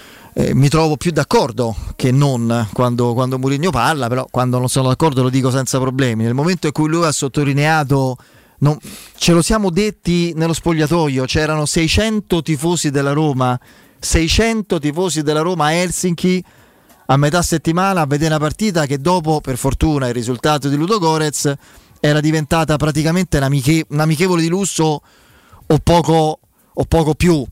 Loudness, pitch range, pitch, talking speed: -16 LUFS, 135-170 Hz, 155 Hz, 165 wpm